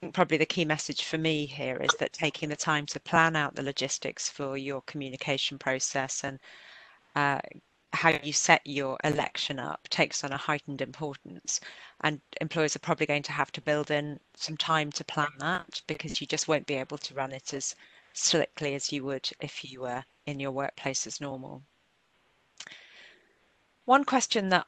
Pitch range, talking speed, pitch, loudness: 140-160 Hz, 180 wpm, 150 Hz, -30 LUFS